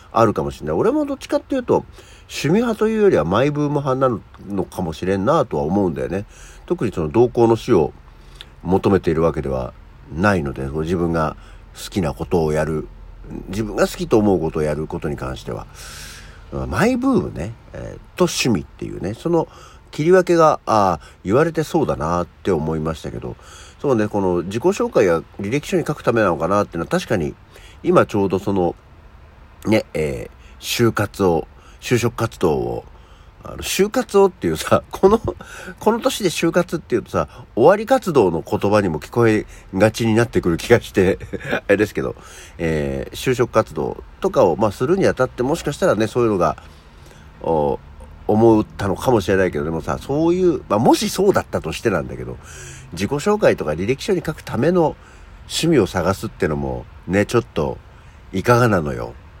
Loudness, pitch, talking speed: -19 LUFS, 105 Hz, 360 characters per minute